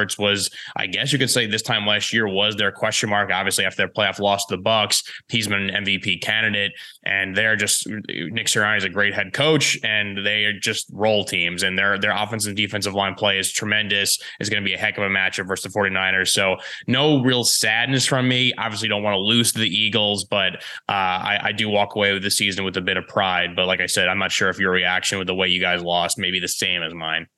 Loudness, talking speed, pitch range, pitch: -20 LUFS, 255 wpm, 95-110 Hz, 100 Hz